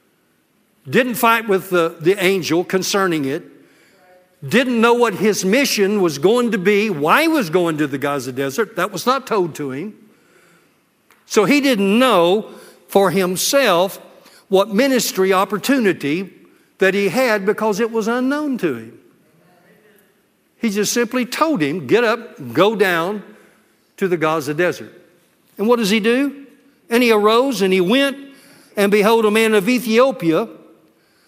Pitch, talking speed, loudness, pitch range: 210 Hz, 150 wpm, -17 LUFS, 180-240 Hz